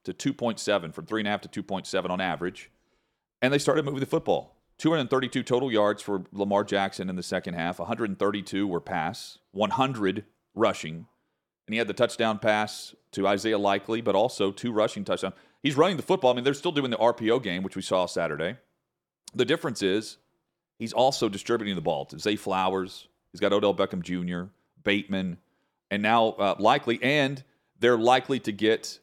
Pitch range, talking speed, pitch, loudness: 100-120 Hz, 175 wpm, 105 Hz, -27 LUFS